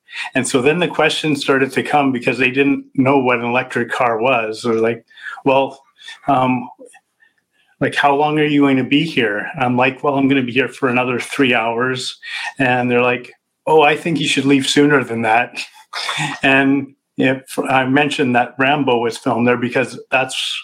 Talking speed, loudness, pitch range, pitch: 195 wpm, -16 LUFS, 125-140 Hz, 135 Hz